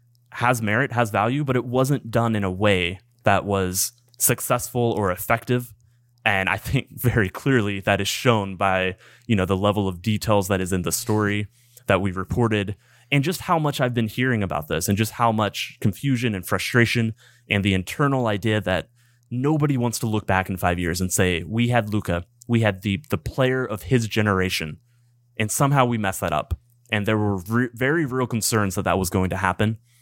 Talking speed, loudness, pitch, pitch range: 200 wpm, -22 LUFS, 110 Hz, 100-120 Hz